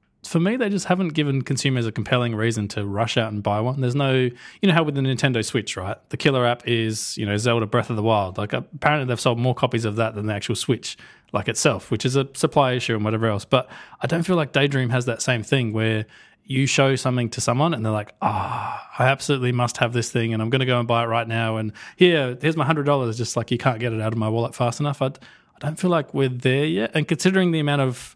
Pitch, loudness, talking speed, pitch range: 125 Hz, -22 LUFS, 270 wpm, 115-140 Hz